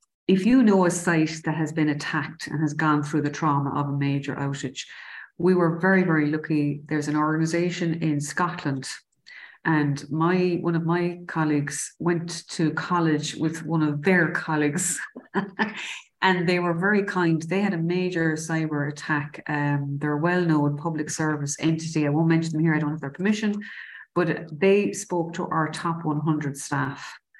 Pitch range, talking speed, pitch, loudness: 150-175 Hz, 175 wpm, 160 Hz, -24 LUFS